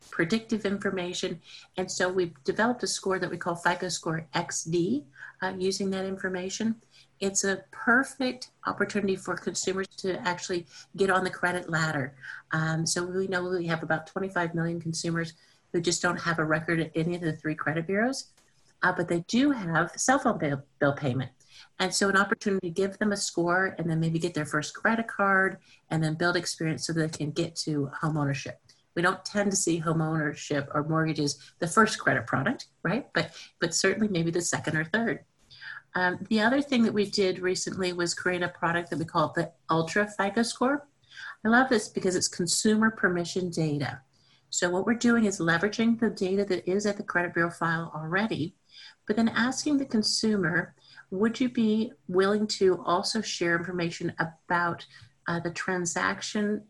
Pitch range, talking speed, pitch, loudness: 165-200 Hz, 185 wpm, 180 Hz, -28 LUFS